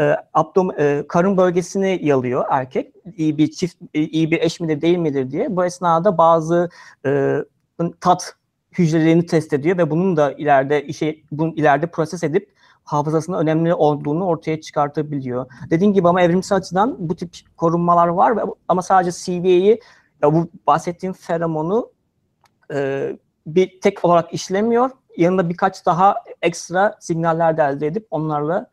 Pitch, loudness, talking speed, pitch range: 170 Hz, -18 LUFS, 145 wpm, 155-185 Hz